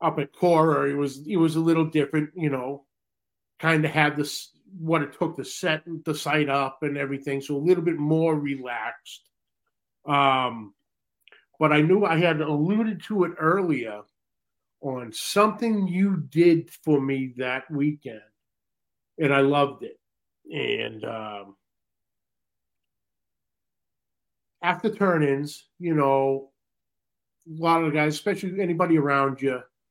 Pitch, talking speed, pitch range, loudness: 150 Hz, 140 wpm, 135-170 Hz, -24 LUFS